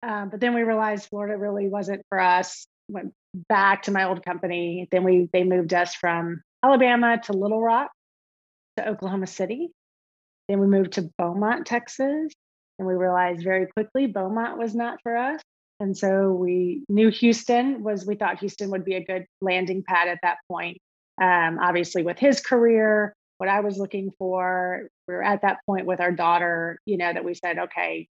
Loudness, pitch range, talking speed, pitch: -23 LUFS, 180-215 Hz, 185 wpm, 195 Hz